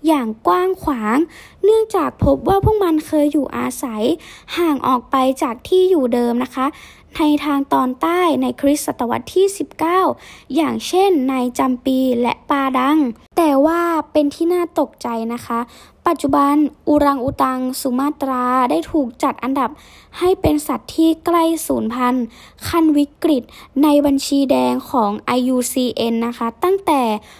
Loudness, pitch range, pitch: -17 LUFS, 255-320 Hz, 285 Hz